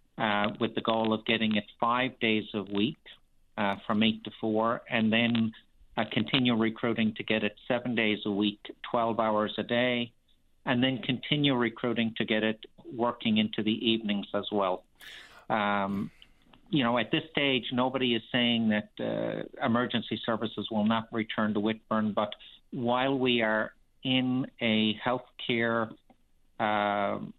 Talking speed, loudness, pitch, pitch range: 160 wpm, -29 LUFS, 115 Hz, 110-120 Hz